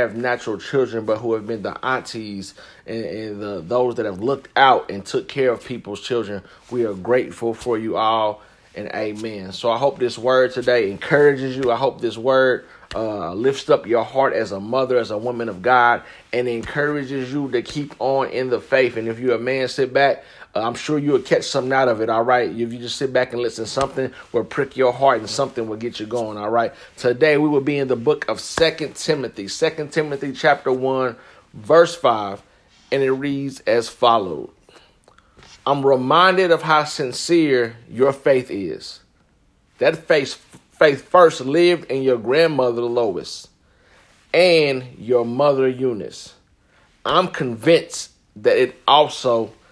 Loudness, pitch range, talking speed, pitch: -19 LUFS, 115-140 Hz, 180 wpm, 125 Hz